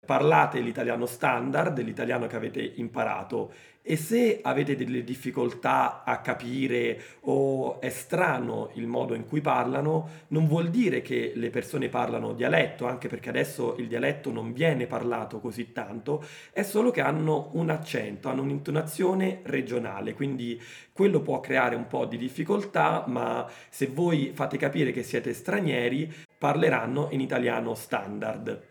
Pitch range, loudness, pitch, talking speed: 120-155 Hz, -28 LUFS, 140 Hz, 145 wpm